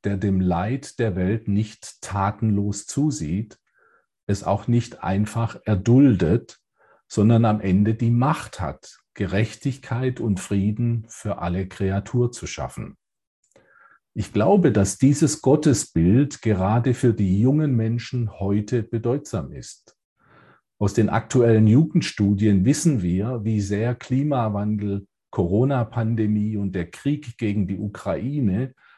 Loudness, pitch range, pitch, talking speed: -22 LUFS, 100-125 Hz, 110 Hz, 115 wpm